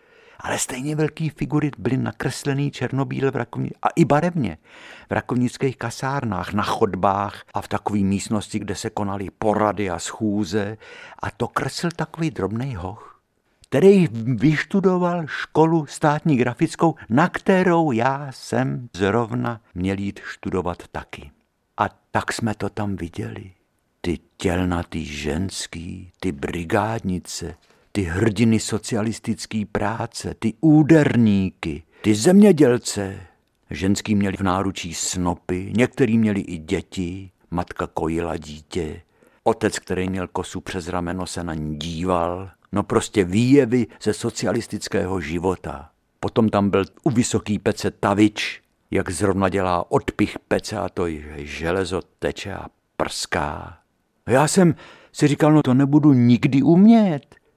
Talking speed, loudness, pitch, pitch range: 125 wpm, -21 LUFS, 105 Hz, 95-135 Hz